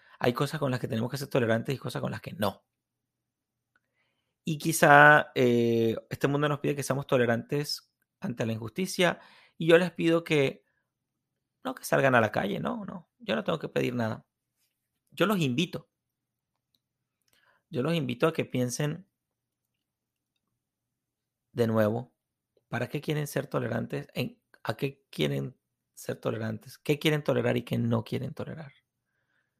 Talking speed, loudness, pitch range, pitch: 155 wpm, -28 LUFS, 120-150 Hz, 135 Hz